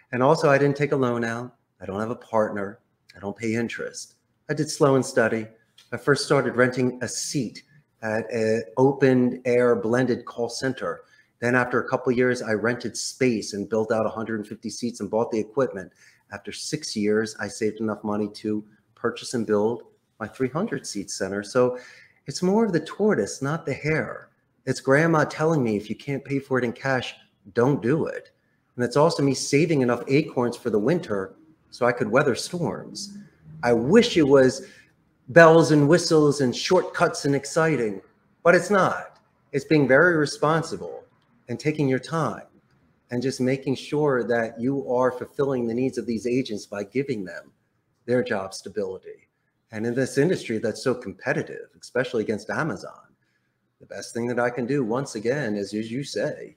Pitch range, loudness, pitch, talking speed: 115-145 Hz, -24 LUFS, 125 Hz, 180 wpm